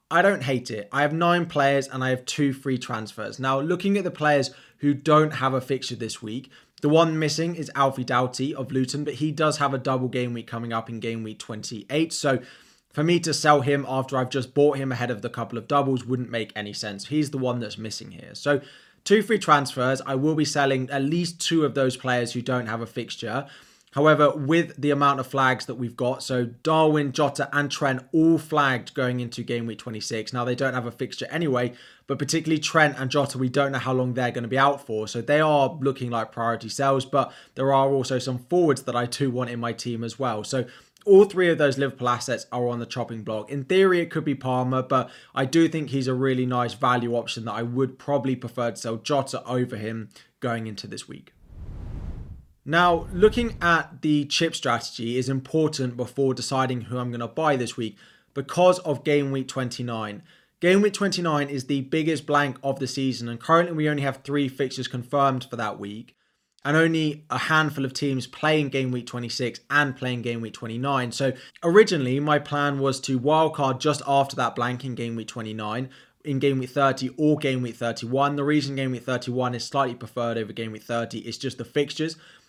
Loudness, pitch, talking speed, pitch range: -24 LUFS, 135 Hz, 215 wpm, 120-145 Hz